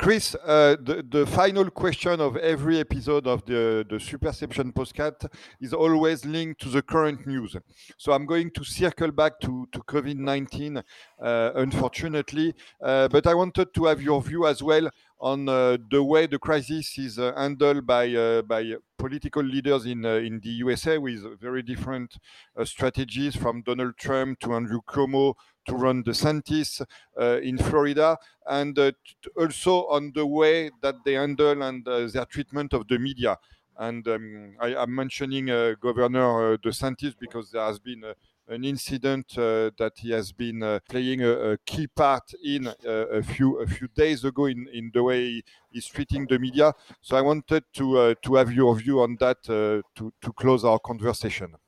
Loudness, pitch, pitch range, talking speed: -25 LUFS, 130 Hz, 120-145 Hz, 180 wpm